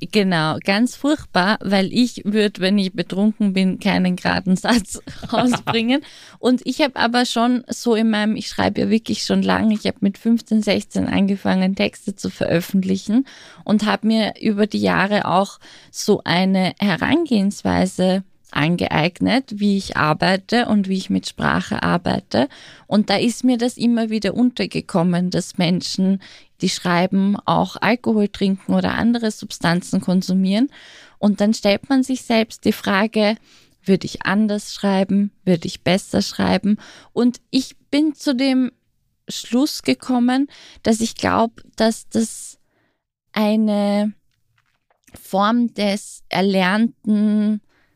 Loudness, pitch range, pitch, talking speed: -19 LUFS, 190-230 Hz, 210 Hz, 135 wpm